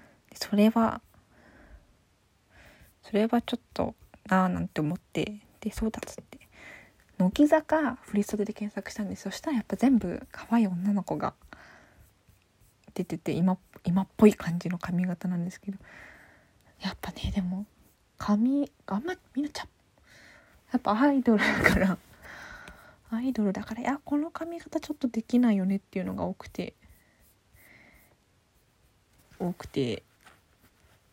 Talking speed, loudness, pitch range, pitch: 270 characters per minute, -29 LUFS, 185-245 Hz, 205 Hz